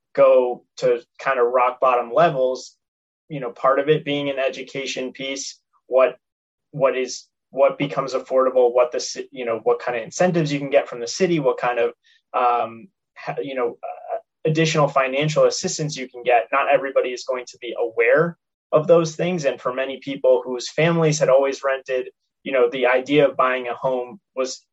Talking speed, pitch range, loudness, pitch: 185 wpm, 130-170 Hz, -21 LUFS, 135 Hz